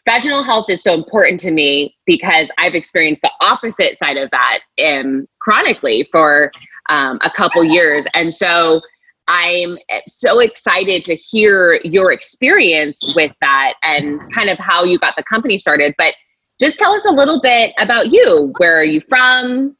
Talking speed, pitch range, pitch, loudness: 165 wpm, 160-255 Hz, 180 Hz, -12 LUFS